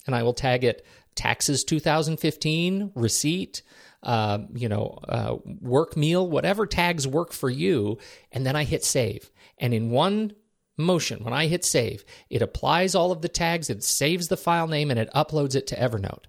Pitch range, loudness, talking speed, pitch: 125-175 Hz, -25 LUFS, 180 wpm, 150 Hz